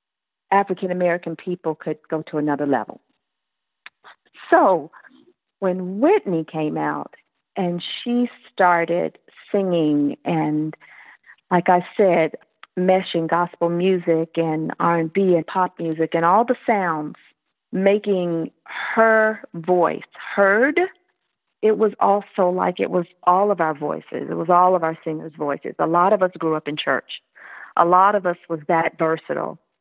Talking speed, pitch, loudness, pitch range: 145 wpm, 175 Hz, -20 LUFS, 160-195 Hz